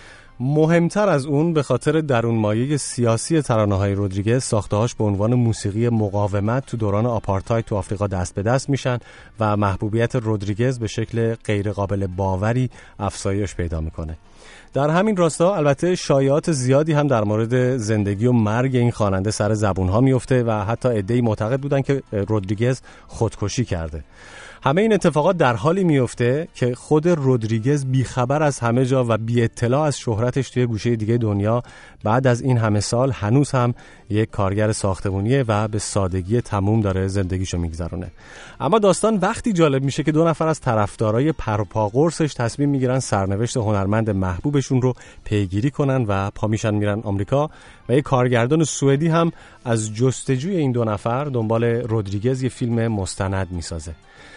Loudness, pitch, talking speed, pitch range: -20 LUFS, 115 Hz, 155 wpm, 105-135 Hz